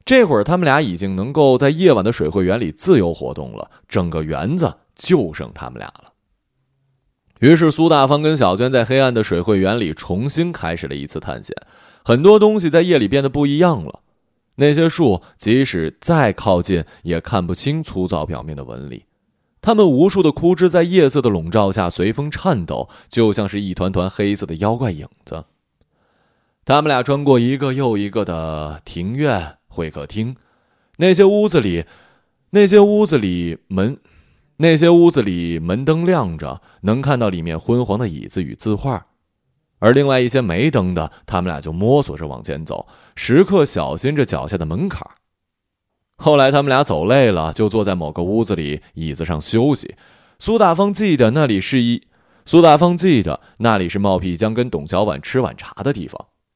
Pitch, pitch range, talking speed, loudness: 115 Hz, 90-150 Hz, 265 characters per minute, -16 LUFS